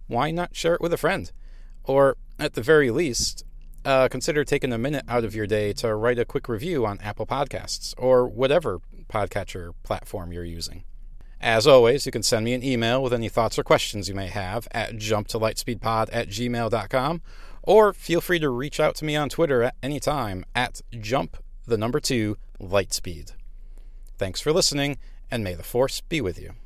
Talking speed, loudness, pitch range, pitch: 180 wpm, -24 LUFS, 100-135 Hz, 115 Hz